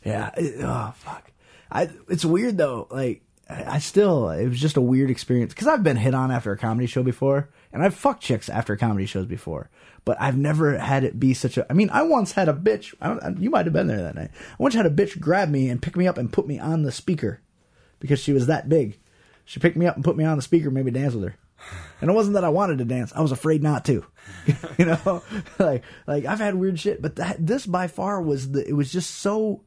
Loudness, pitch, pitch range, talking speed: -23 LUFS, 150 Hz, 130-180 Hz, 260 wpm